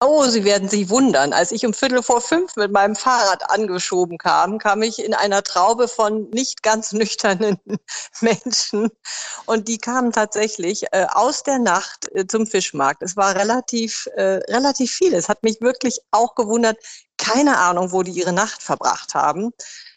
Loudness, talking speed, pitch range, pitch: -19 LUFS, 170 wpm, 200-240 Hz, 220 Hz